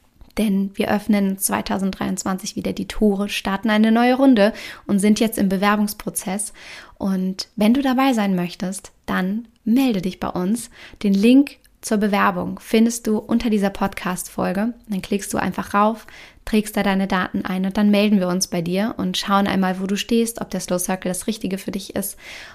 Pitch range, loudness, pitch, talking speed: 190-220 Hz, -20 LUFS, 205 Hz, 180 wpm